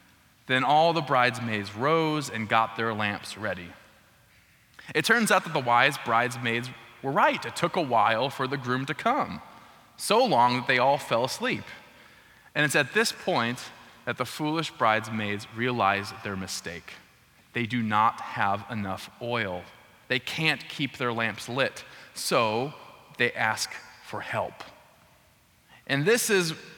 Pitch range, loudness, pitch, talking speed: 110-140 Hz, -26 LUFS, 120 Hz, 150 wpm